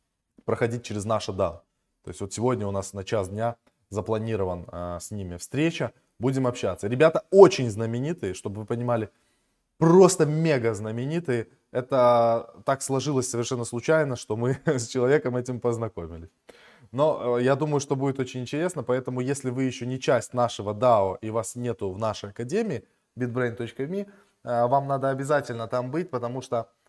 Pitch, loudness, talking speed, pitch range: 120 Hz, -25 LUFS, 160 wpm, 110-135 Hz